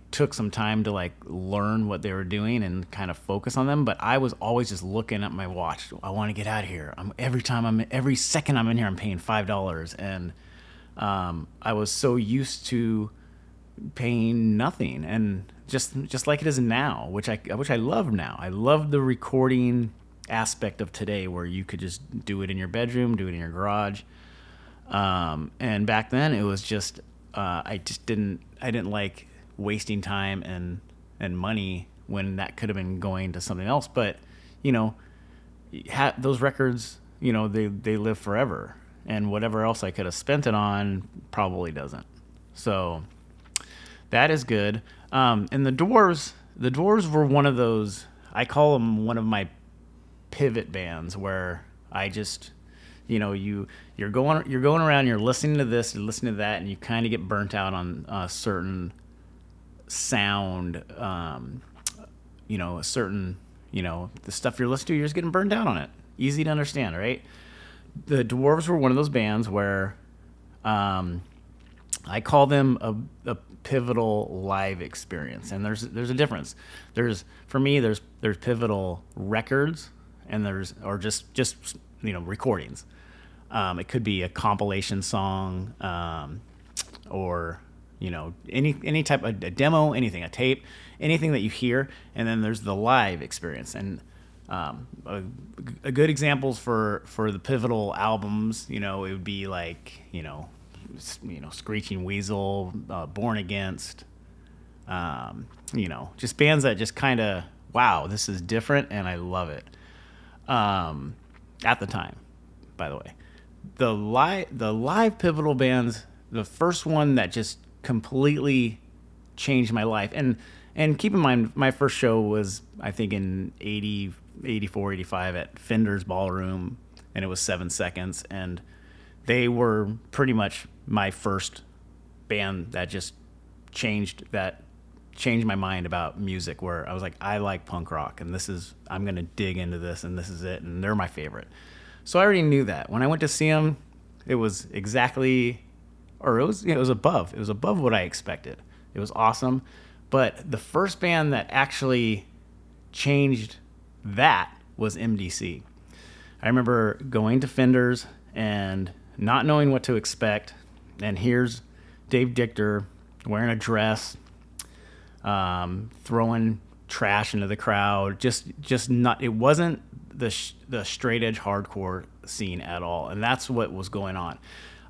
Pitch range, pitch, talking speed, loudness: 90-120 Hz, 105 Hz, 170 wpm, -26 LUFS